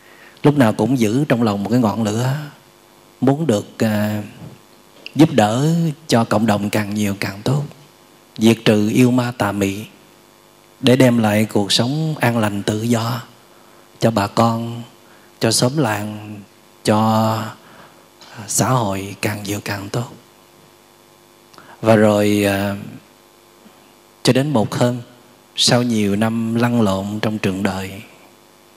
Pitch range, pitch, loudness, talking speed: 105-120 Hz, 115 Hz, -17 LUFS, 135 wpm